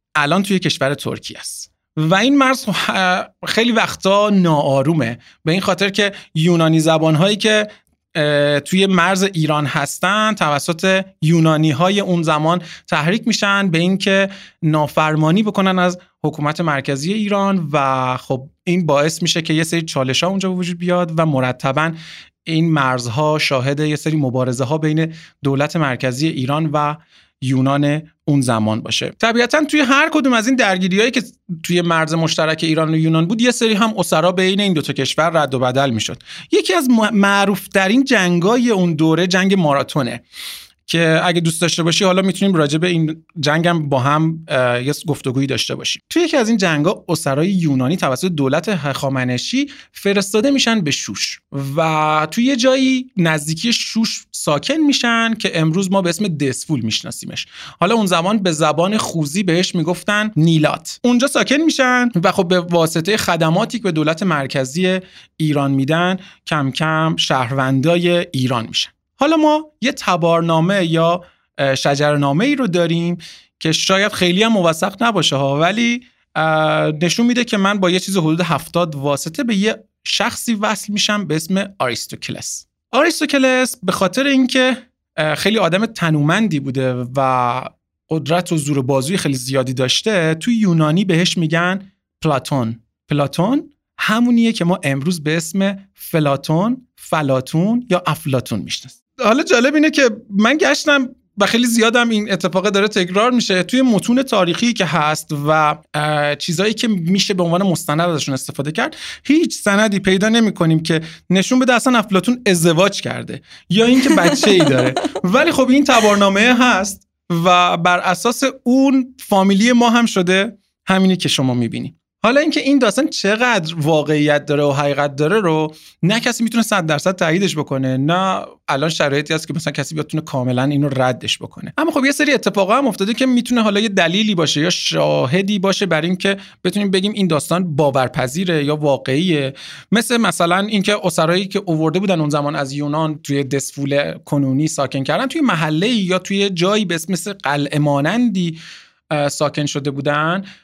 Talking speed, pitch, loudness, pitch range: 155 wpm, 175 Hz, -16 LUFS, 150-210 Hz